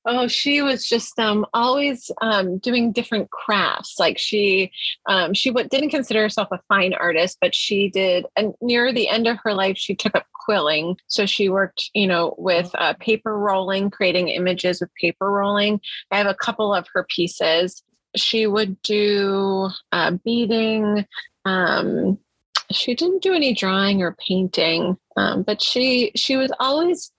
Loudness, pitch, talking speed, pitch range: -20 LUFS, 205 Hz, 165 wpm, 190-235 Hz